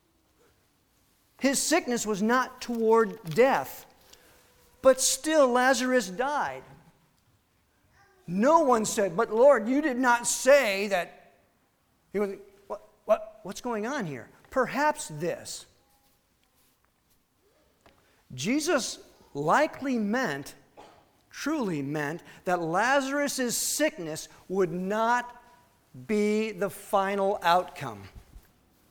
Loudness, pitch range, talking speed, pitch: -26 LUFS, 170-260 Hz, 90 wpm, 220 Hz